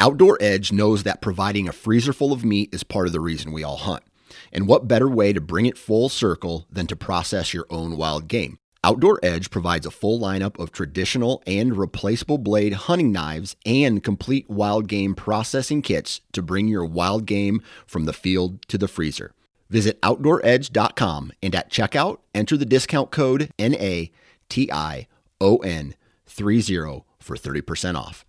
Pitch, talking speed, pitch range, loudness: 100 Hz, 175 wpm, 90-120 Hz, -22 LUFS